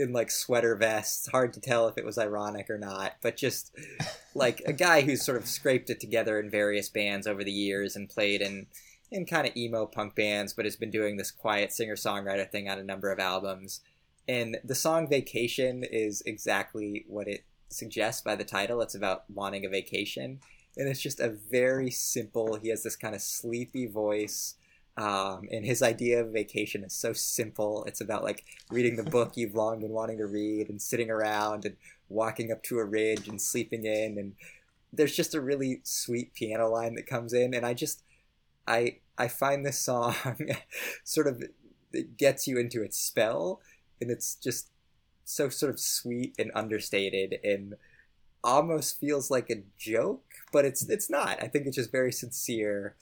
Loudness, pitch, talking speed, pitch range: -30 LUFS, 110 Hz, 190 wpm, 105-120 Hz